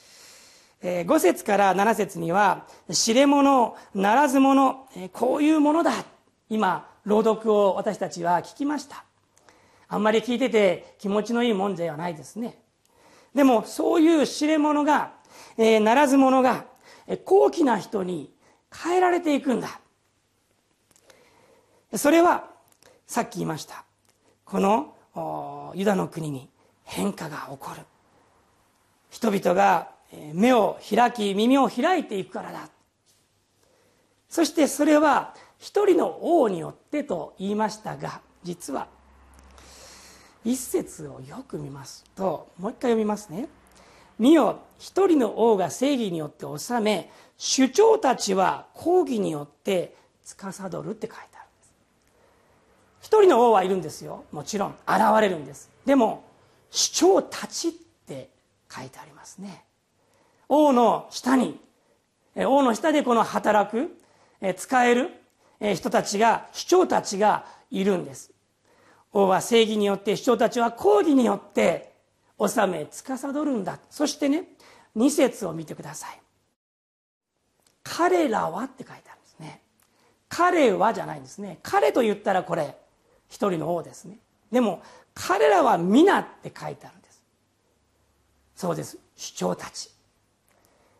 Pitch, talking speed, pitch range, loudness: 225 Hz, 245 characters per minute, 190-290 Hz, -23 LUFS